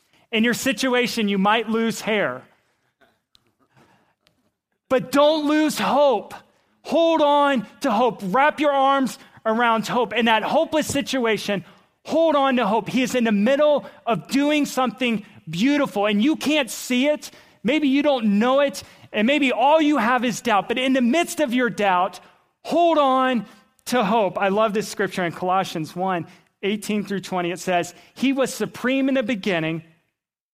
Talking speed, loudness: 165 wpm, -21 LUFS